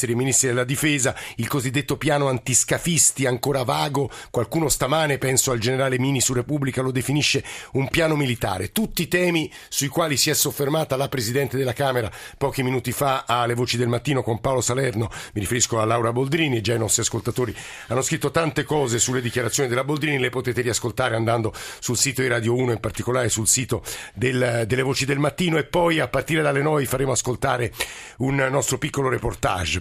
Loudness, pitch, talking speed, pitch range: -22 LUFS, 130 Hz, 185 wpm, 120-140 Hz